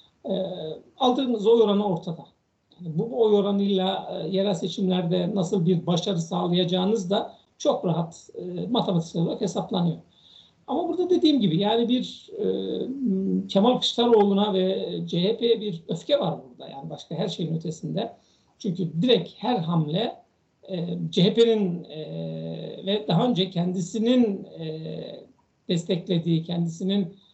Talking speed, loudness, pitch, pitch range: 125 wpm, -25 LUFS, 195 Hz, 175-220 Hz